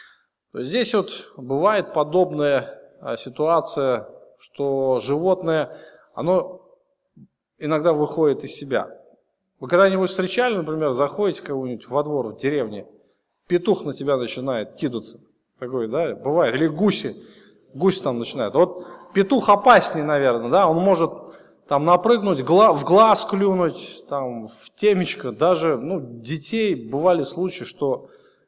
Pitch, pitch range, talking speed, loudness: 170 Hz, 140-200 Hz, 120 wpm, -21 LUFS